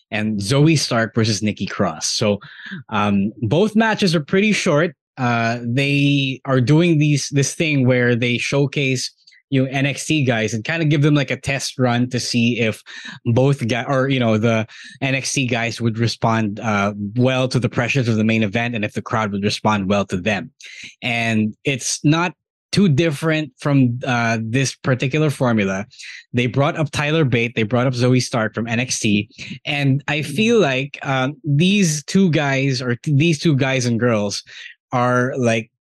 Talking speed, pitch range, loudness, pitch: 180 wpm, 115-145 Hz, -18 LUFS, 130 Hz